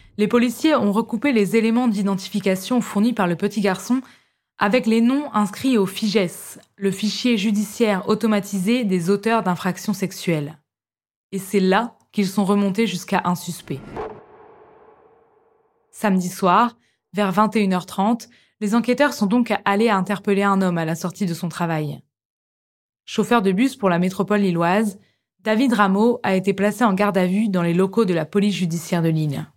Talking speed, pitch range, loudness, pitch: 160 wpm, 185-230 Hz, -20 LUFS, 205 Hz